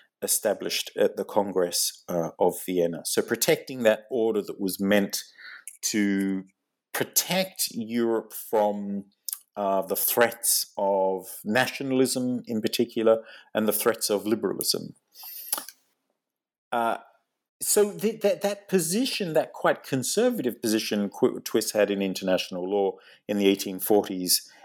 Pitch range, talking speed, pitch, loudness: 100-145 Hz, 115 wpm, 110 Hz, -26 LUFS